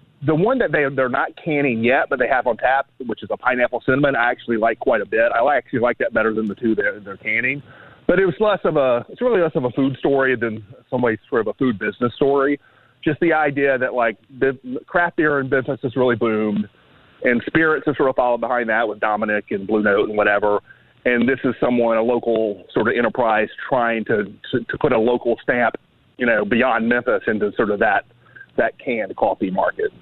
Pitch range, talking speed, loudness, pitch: 115-140 Hz, 230 wpm, -19 LUFS, 125 Hz